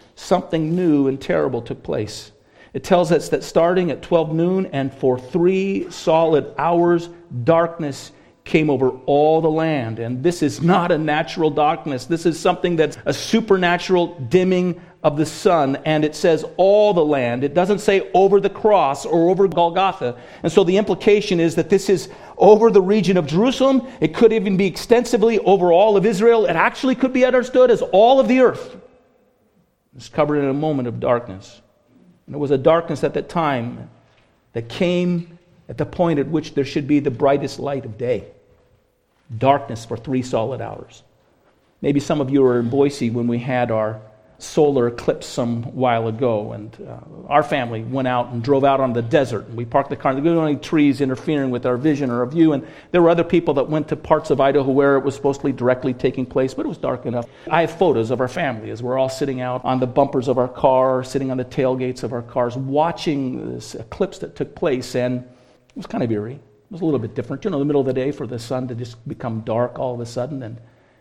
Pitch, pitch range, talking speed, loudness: 145 Hz, 125-175 Hz, 215 wpm, -19 LUFS